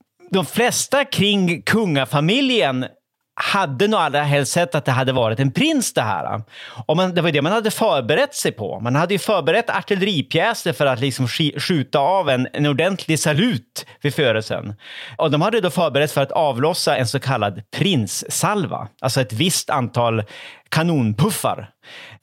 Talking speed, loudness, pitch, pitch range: 165 wpm, -19 LUFS, 155 Hz, 135-190 Hz